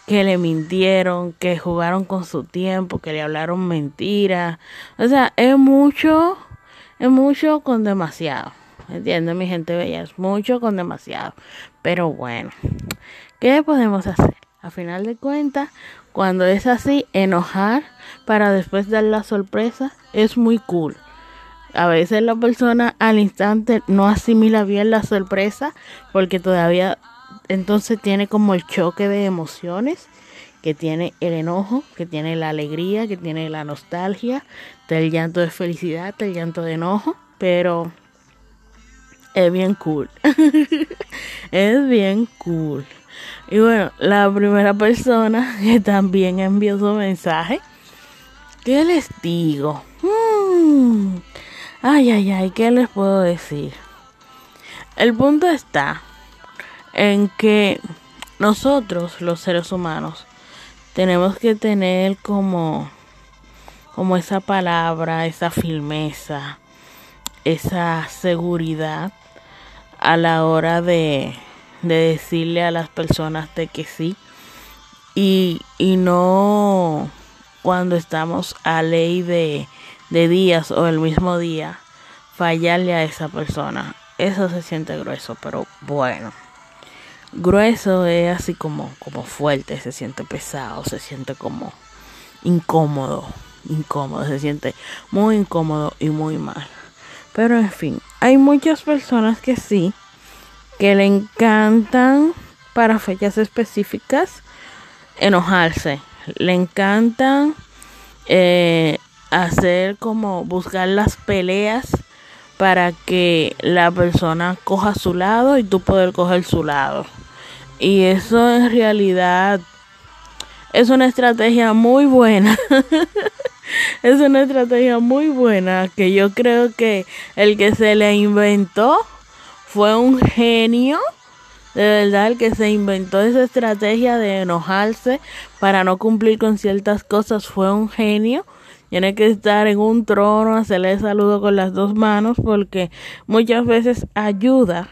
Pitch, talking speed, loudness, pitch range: 195 Hz, 120 wpm, -17 LUFS, 175-230 Hz